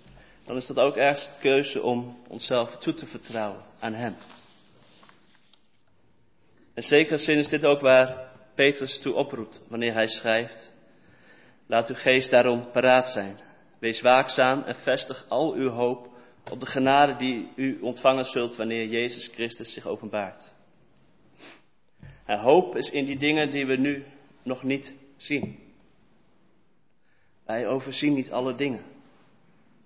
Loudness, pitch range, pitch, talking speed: -25 LUFS, 120-140 Hz, 130 Hz, 140 wpm